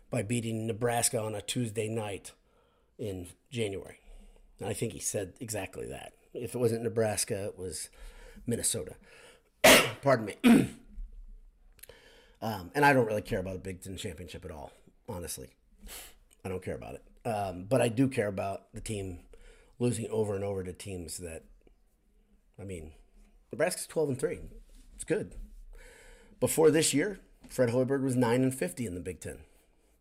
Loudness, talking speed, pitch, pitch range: -30 LUFS, 160 wpm, 110 Hz, 95-125 Hz